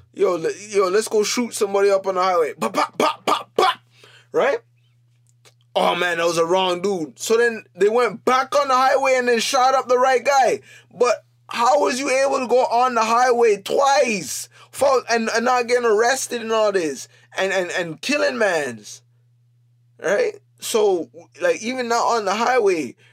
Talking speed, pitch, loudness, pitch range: 180 wpm, 225 Hz, -19 LUFS, 175-255 Hz